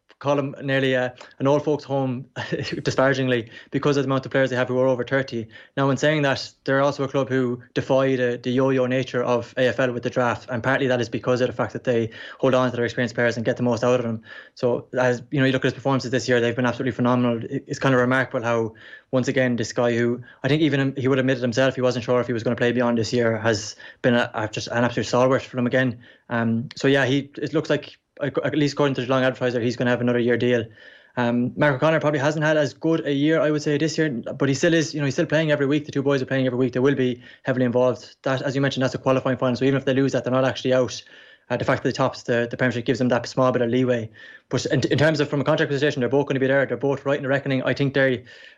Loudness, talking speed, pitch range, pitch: -22 LUFS, 290 wpm, 125-140 Hz, 130 Hz